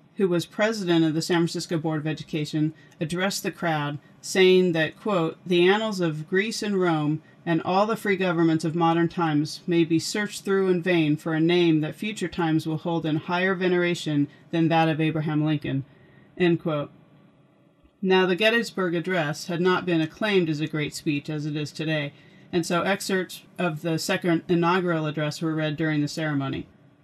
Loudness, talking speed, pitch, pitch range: -24 LUFS, 185 wpm, 170 Hz, 155-180 Hz